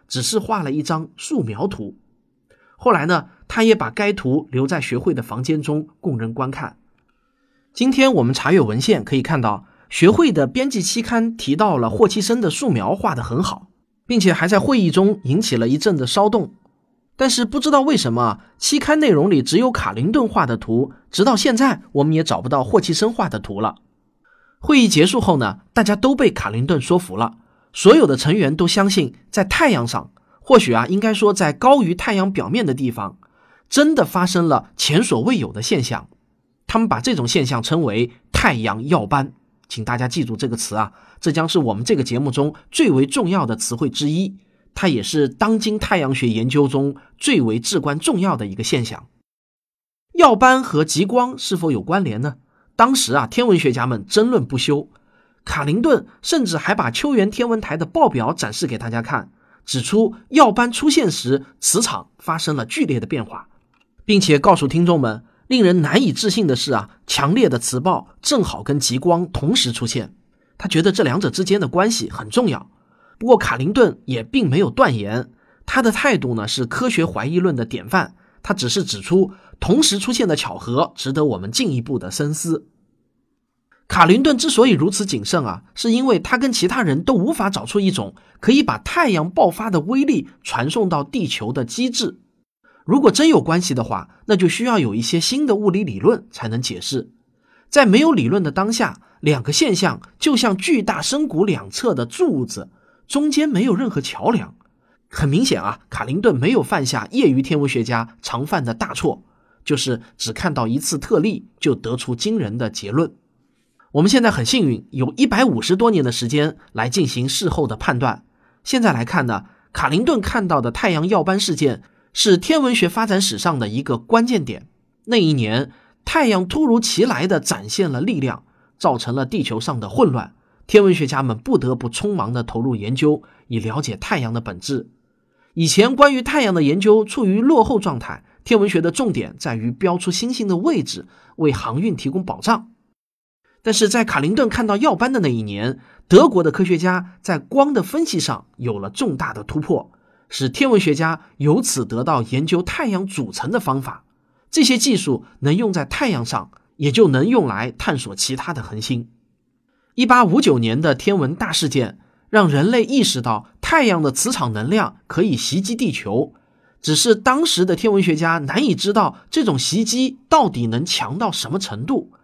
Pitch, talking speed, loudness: 175 Hz, 275 characters per minute, -18 LUFS